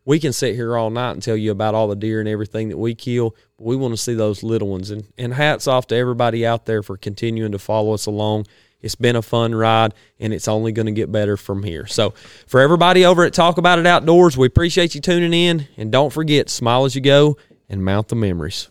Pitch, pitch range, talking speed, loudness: 115 Hz, 110-135 Hz, 255 wpm, -17 LUFS